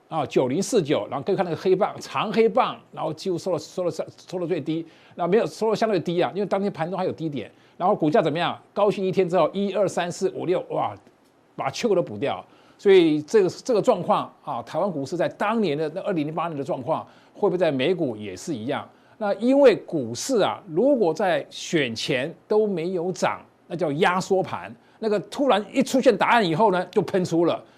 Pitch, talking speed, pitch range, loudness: 190 Hz, 320 characters per minute, 165-210 Hz, -23 LUFS